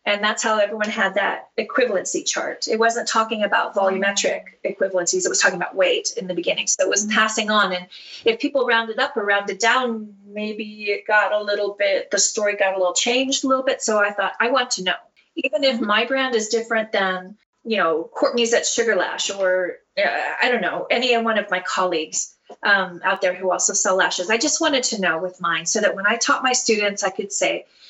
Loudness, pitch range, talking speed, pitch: -20 LUFS, 195-235 Hz, 225 wpm, 210 Hz